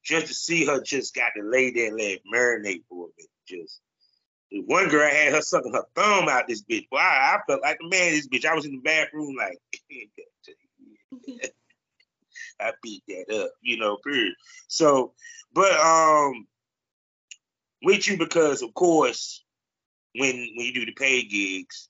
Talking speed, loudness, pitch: 180 wpm, -23 LUFS, 165 Hz